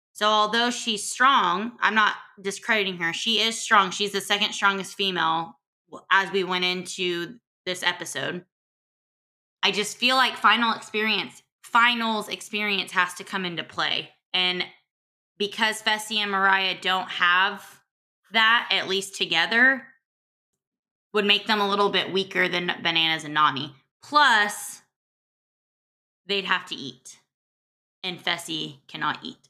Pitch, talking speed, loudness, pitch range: 195 Hz, 135 wpm, -23 LUFS, 175-215 Hz